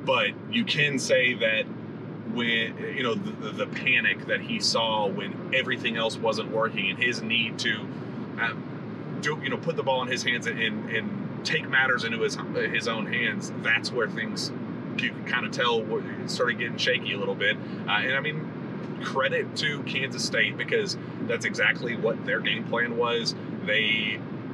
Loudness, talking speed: -26 LUFS, 180 wpm